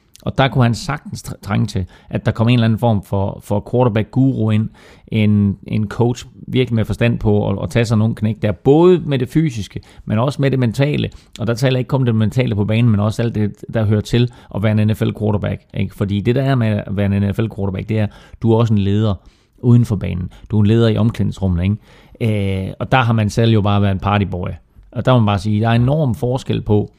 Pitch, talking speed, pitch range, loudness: 110 Hz, 250 wpm, 100-120 Hz, -17 LUFS